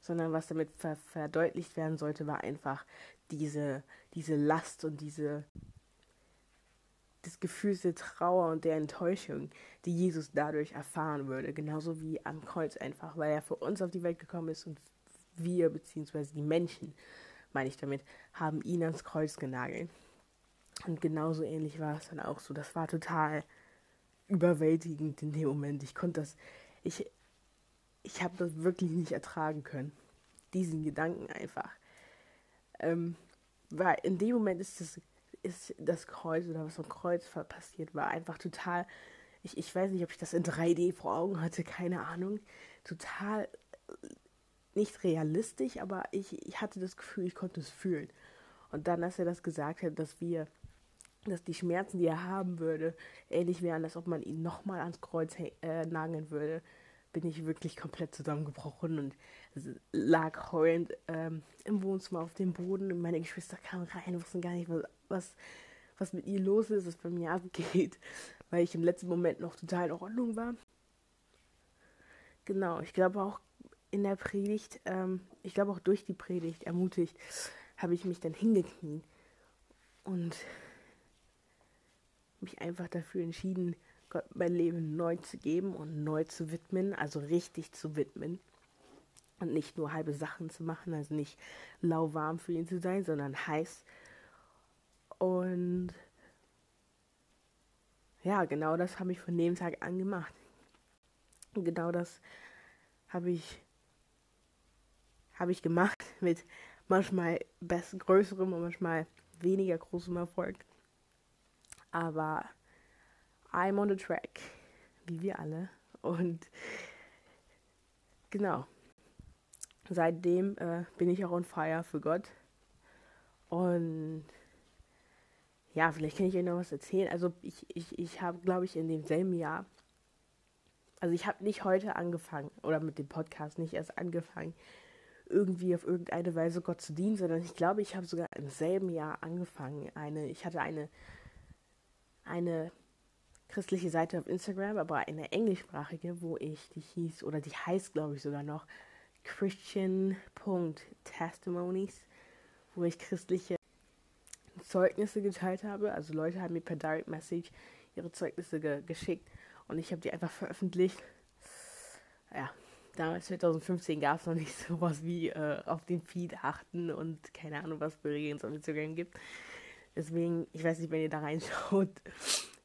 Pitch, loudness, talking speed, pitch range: 170 Hz, -36 LUFS, 150 wpm, 155-180 Hz